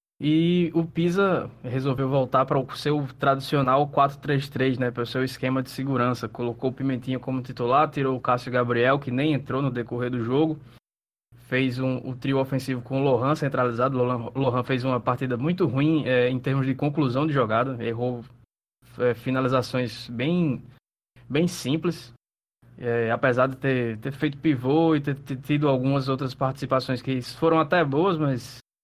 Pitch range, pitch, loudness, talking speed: 125-145 Hz, 130 Hz, -25 LUFS, 170 wpm